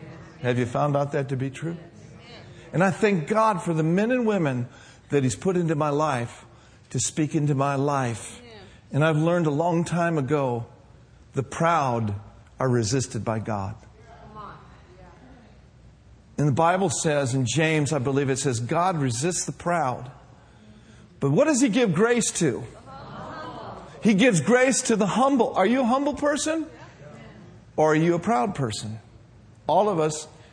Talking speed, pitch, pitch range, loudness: 160 wpm, 145 Hz, 120-175 Hz, -24 LUFS